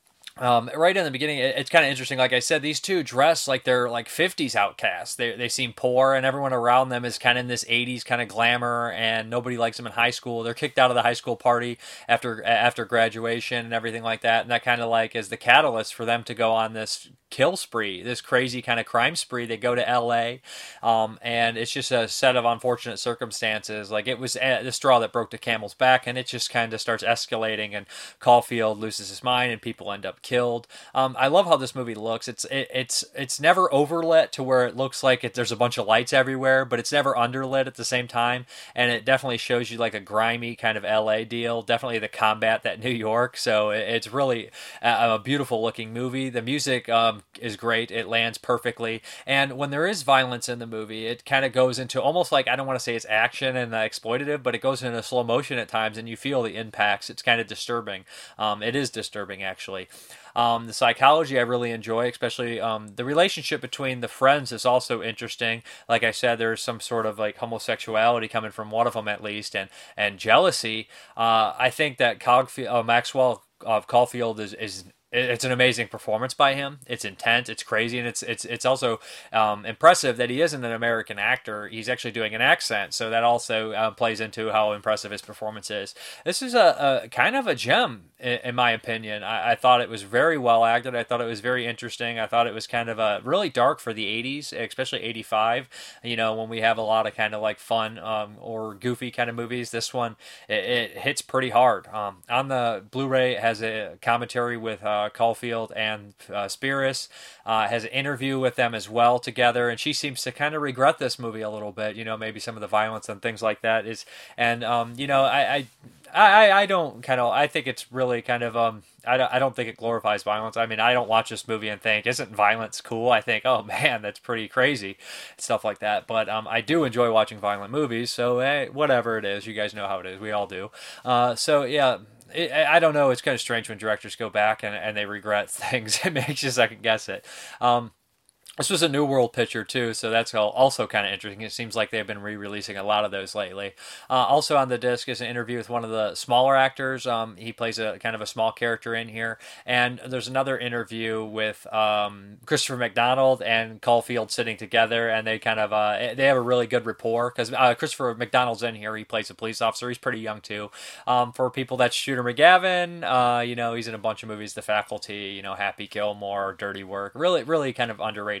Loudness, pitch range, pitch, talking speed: -24 LUFS, 110-125 Hz, 120 Hz, 230 wpm